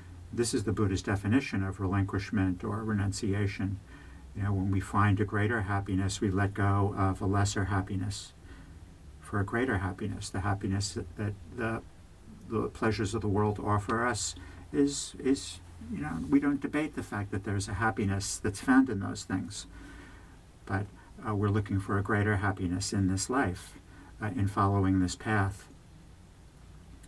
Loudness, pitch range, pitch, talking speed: -31 LUFS, 95-105 Hz, 100 Hz, 165 wpm